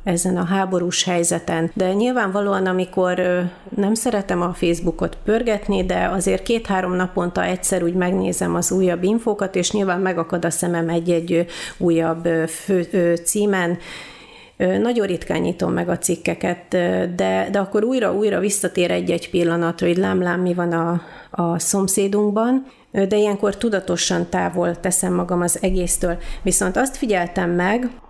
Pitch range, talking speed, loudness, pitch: 175-200 Hz, 135 wpm, -20 LUFS, 180 Hz